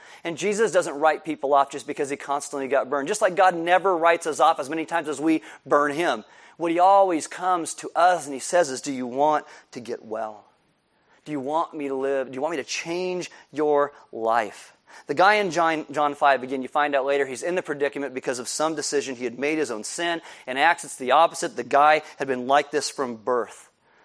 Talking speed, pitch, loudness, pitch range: 235 wpm, 150 Hz, -23 LUFS, 140-170 Hz